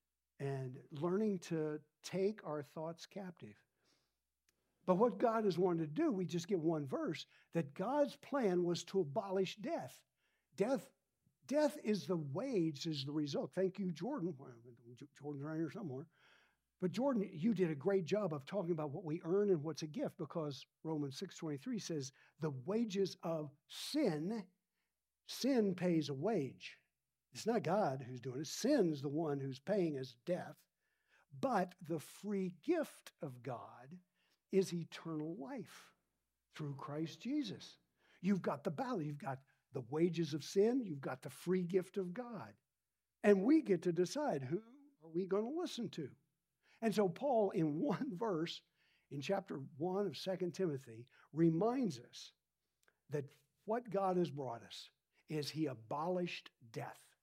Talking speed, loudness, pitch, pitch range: 155 wpm, -40 LUFS, 170 Hz, 150-195 Hz